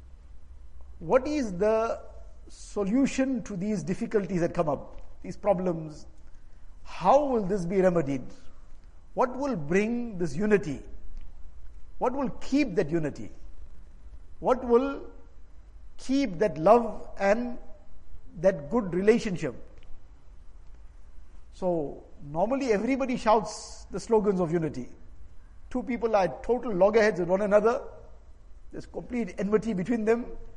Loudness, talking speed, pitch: -27 LUFS, 110 wpm, 185 Hz